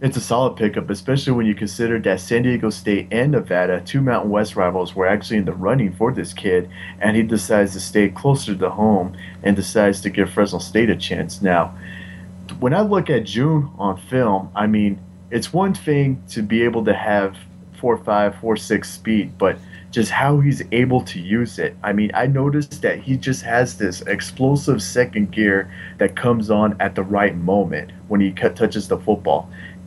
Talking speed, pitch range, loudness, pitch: 195 wpm, 95-120 Hz, -19 LUFS, 105 Hz